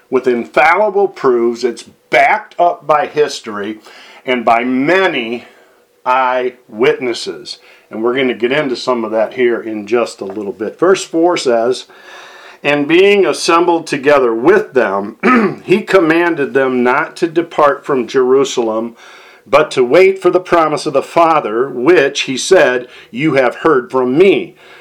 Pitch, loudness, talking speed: 170 Hz, -13 LUFS, 150 wpm